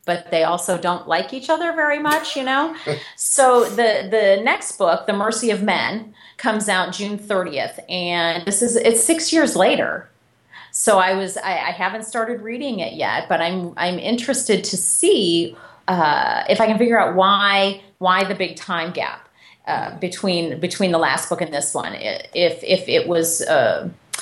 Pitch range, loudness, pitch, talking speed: 180-265 Hz, -19 LUFS, 205 Hz, 180 wpm